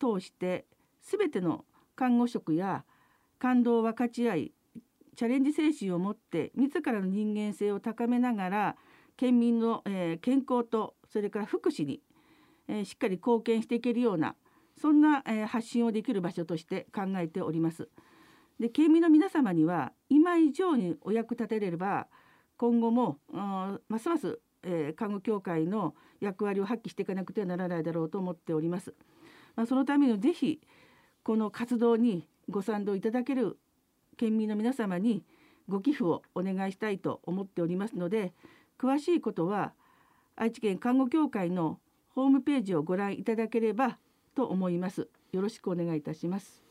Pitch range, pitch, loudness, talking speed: 190-255 Hz, 225 Hz, -30 LUFS, 310 characters per minute